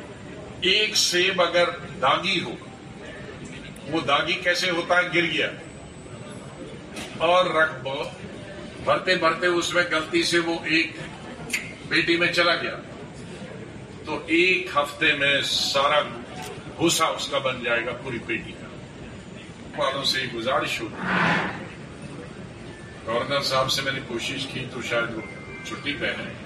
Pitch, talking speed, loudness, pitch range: 165 Hz, 130 wpm, -23 LUFS, 135-175 Hz